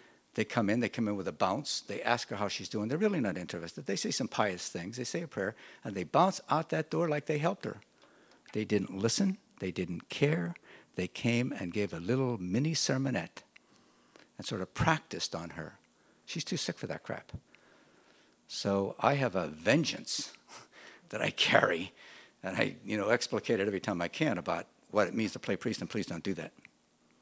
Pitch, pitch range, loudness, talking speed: 105 Hz, 90-130 Hz, -33 LUFS, 205 wpm